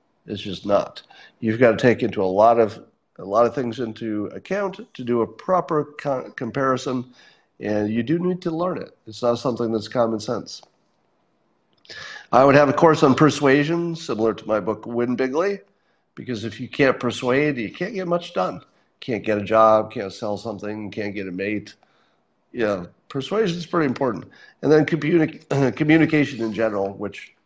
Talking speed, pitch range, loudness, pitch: 180 wpm, 110-150 Hz, -21 LUFS, 120 Hz